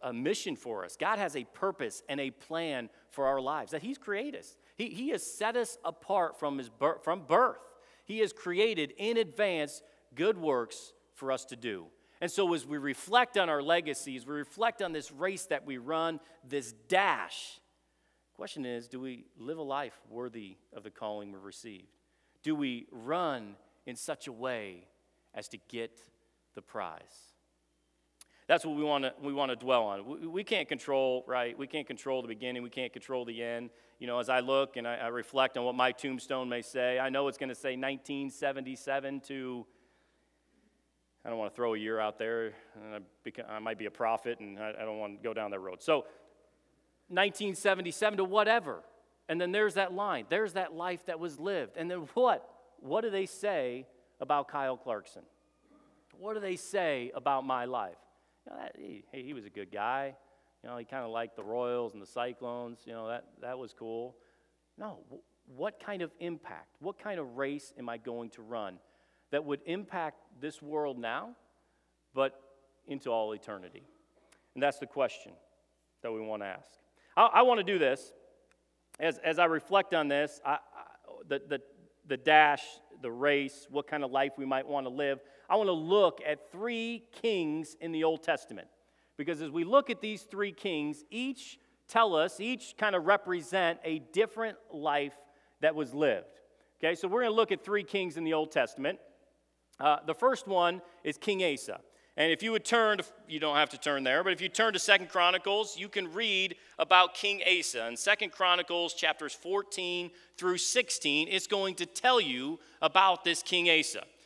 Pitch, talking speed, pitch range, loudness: 150 Hz, 195 wpm, 125-190 Hz, -32 LUFS